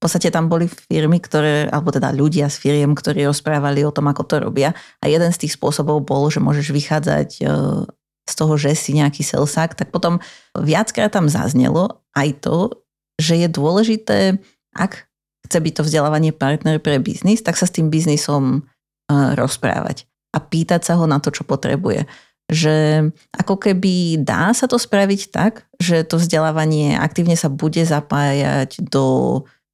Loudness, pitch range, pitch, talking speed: -17 LUFS, 145-170 Hz, 155 Hz, 165 wpm